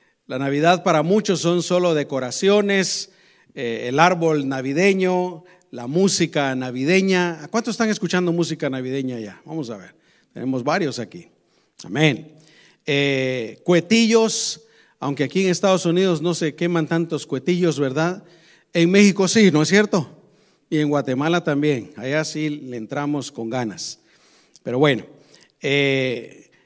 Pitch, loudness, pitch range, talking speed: 160 Hz, -20 LUFS, 140-185 Hz, 135 wpm